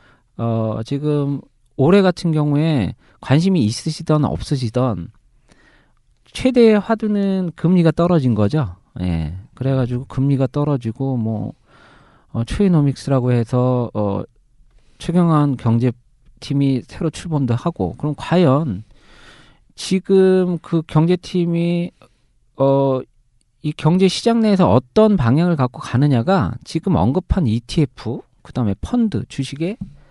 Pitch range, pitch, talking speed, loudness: 120-170 Hz, 140 Hz, 245 characters per minute, -18 LUFS